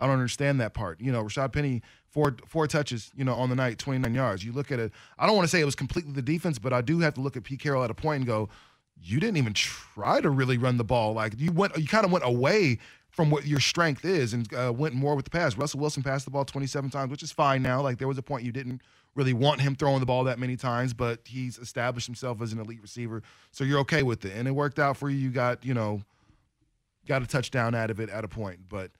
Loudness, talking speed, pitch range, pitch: -28 LUFS, 280 wpm, 120-140 Hz, 130 Hz